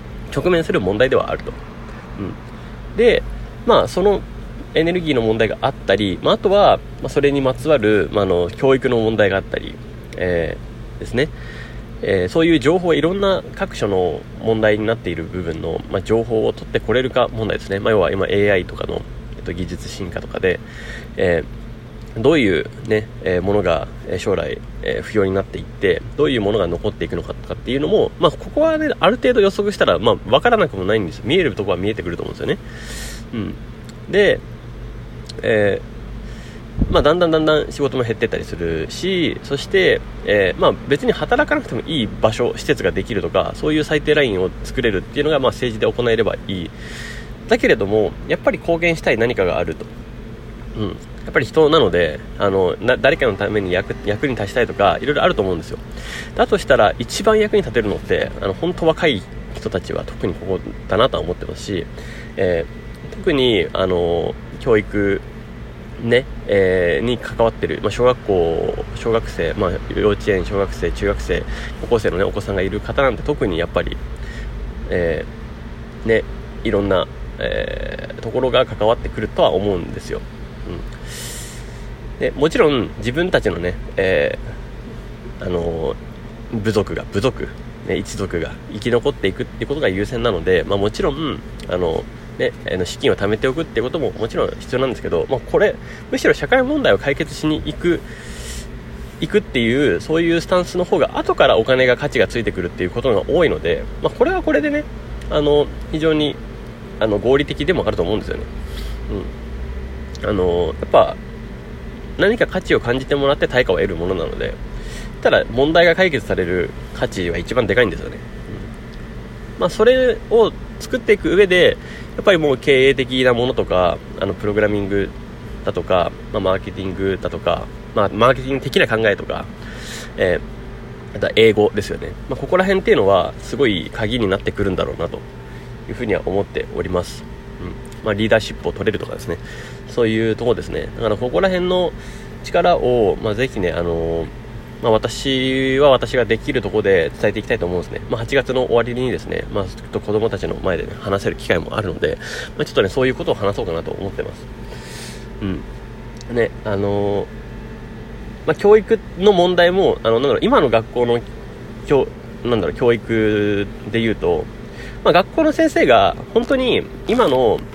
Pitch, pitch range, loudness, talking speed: 120 Hz, 105-170 Hz, -18 LUFS, 355 characters per minute